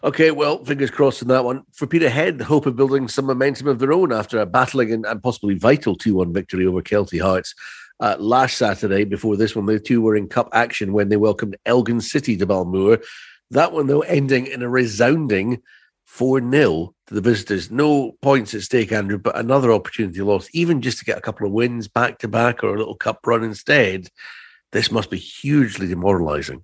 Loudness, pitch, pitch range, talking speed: -19 LUFS, 115 Hz, 105-135 Hz, 210 wpm